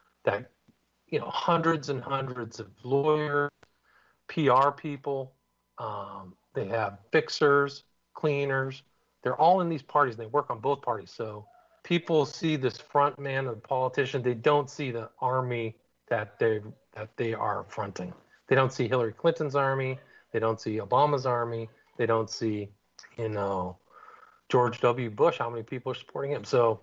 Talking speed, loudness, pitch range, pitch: 160 wpm, -29 LUFS, 115-145 Hz, 130 Hz